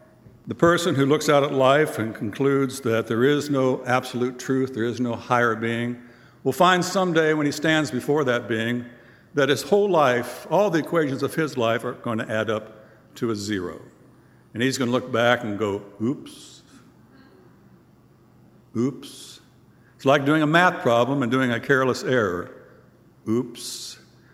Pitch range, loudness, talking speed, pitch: 120-145 Hz, -22 LUFS, 170 wpm, 125 Hz